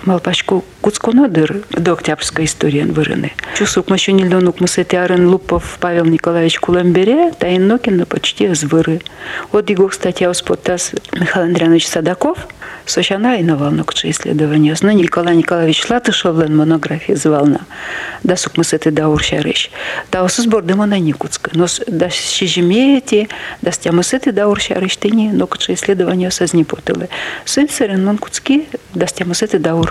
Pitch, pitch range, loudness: 180 Hz, 165-205 Hz, -14 LUFS